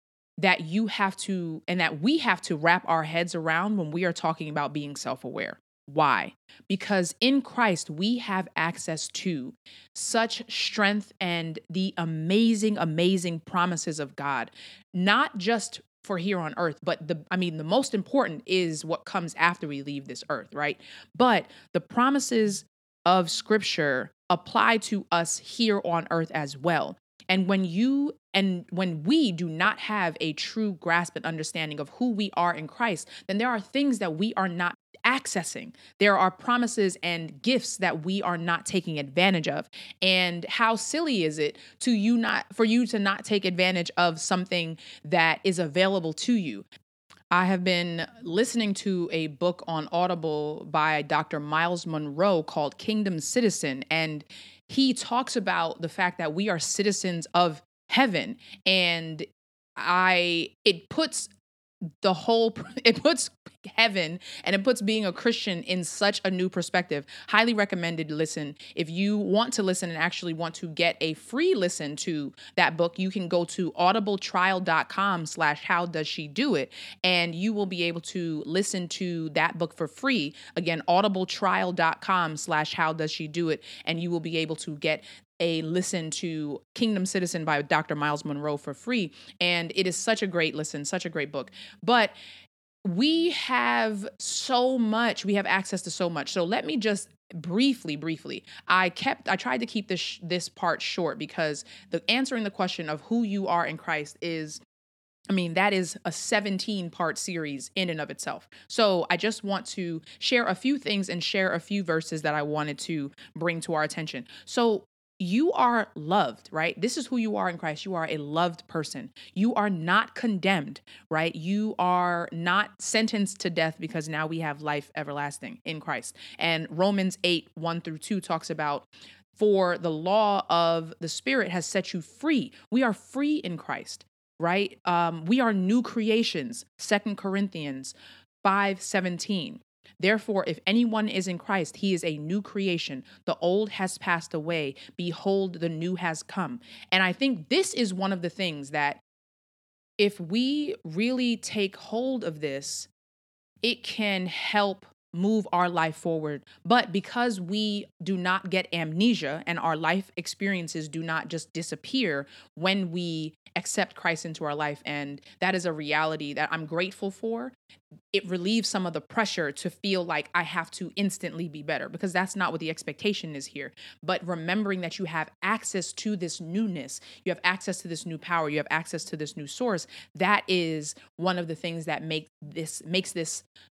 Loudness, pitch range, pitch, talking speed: -27 LUFS, 160-205 Hz, 180 Hz, 175 wpm